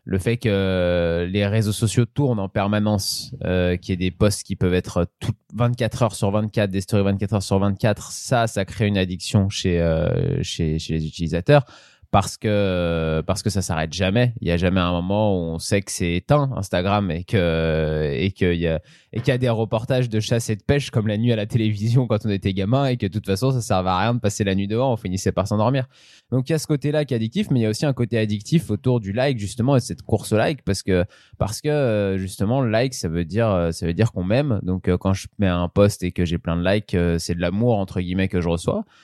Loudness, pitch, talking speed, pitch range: -22 LUFS, 100 Hz, 255 wpm, 90-115 Hz